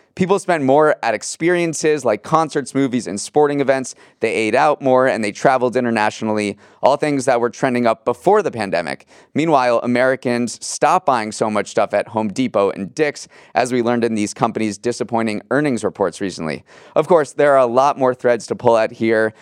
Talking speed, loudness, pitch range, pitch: 190 wpm, -17 LUFS, 115-140 Hz, 125 Hz